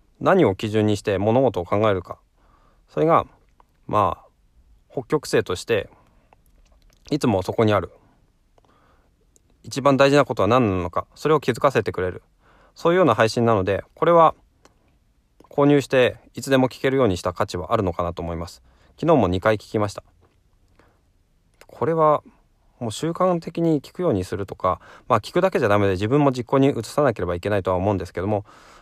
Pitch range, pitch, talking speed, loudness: 95-140 Hz, 110 Hz, 340 characters per minute, -21 LUFS